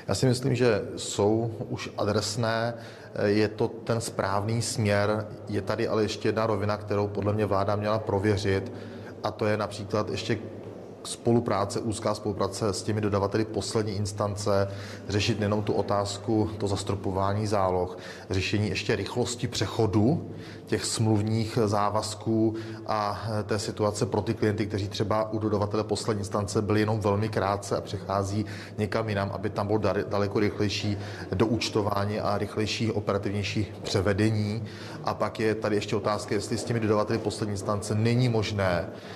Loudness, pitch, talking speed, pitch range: -28 LUFS, 105 Hz, 145 wpm, 100-110 Hz